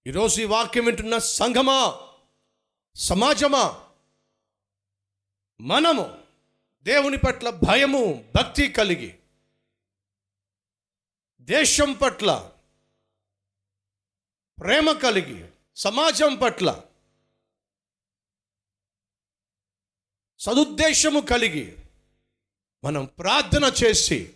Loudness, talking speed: -21 LUFS, 60 wpm